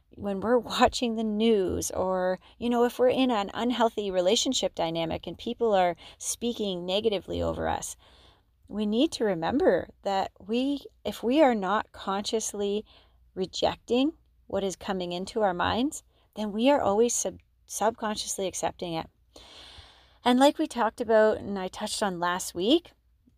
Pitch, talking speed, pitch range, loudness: 210 Hz, 150 wpm, 185-235 Hz, -27 LUFS